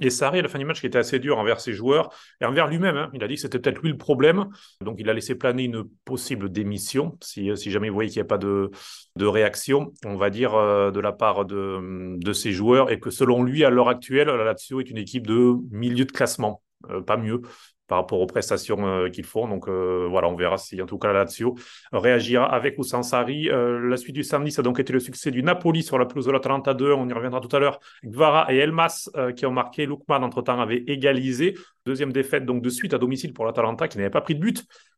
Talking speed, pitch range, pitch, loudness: 255 wpm, 110-140 Hz, 125 Hz, -23 LUFS